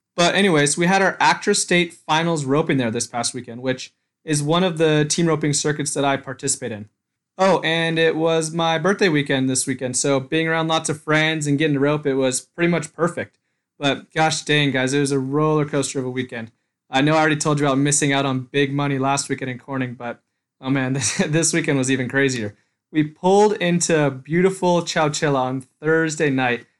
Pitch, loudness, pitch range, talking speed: 145 Hz, -20 LUFS, 135-160 Hz, 210 wpm